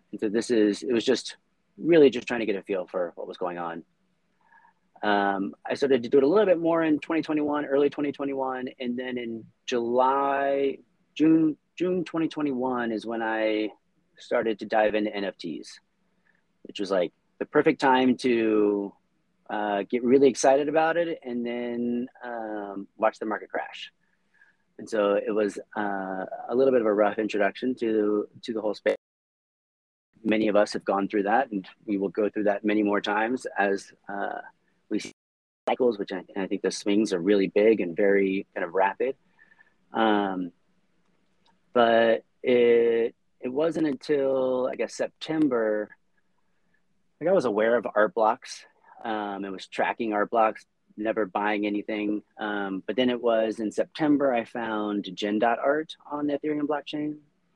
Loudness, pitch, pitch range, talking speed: -26 LUFS, 115 Hz, 105-135 Hz, 165 wpm